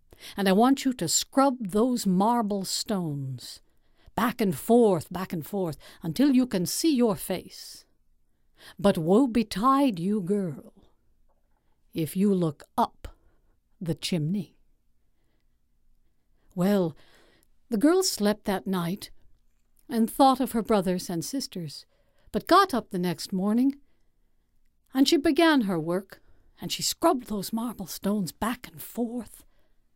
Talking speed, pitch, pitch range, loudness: 130 wpm, 205 Hz, 175-240 Hz, -26 LUFS